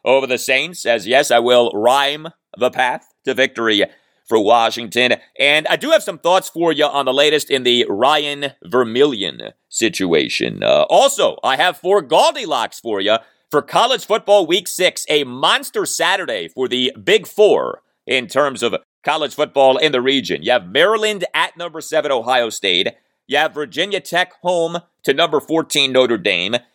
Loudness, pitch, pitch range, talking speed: -16 LUFS, 150 Hz, 130-180 Hz, 170 wpm